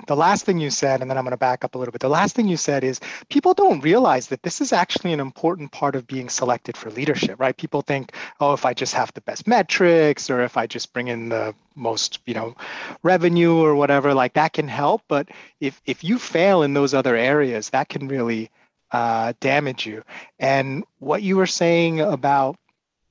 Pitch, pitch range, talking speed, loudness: 140 Hz, 130-165 Hz, 220 wpm, -20 LUFS